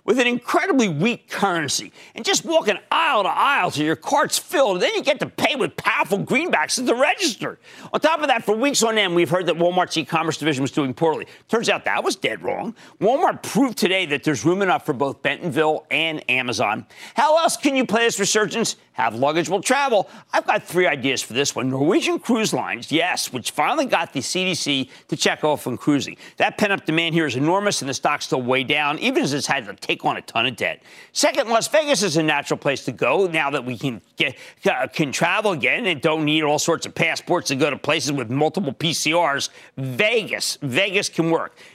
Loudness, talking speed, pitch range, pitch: -20 LUFS, 220 wpm, 145-215 Hz, 165 Hz